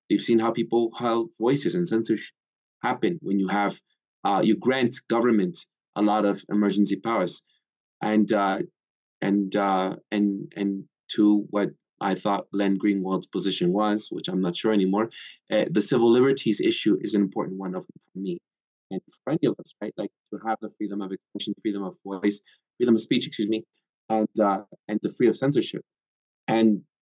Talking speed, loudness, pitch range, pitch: 180 wpm, -25 LUFS, 100-115 Hz, 105 Hz